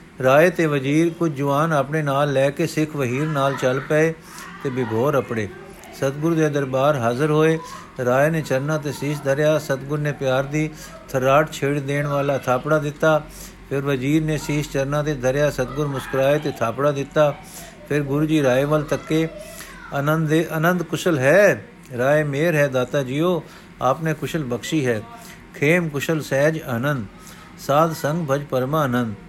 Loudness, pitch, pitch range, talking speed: -21 LUFS, 150 Hz, 135-160 Hz, 160 wpm